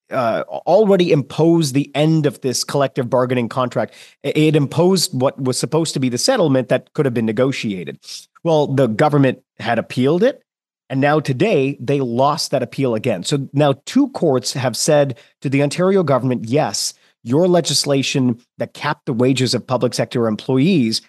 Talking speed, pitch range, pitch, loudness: 170 wpm, 125-150 Hz, 140 Hz, -17 LUFS